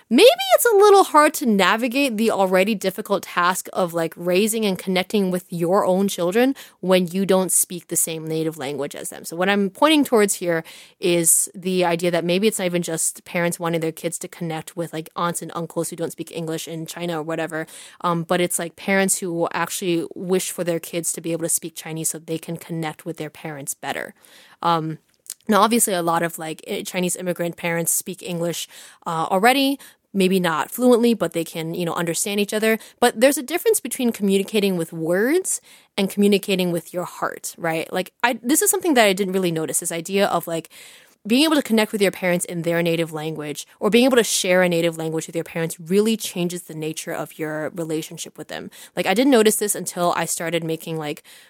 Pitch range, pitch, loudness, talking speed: 165-205 Hz, 175 Hz, -21 LUFS, 215 wpm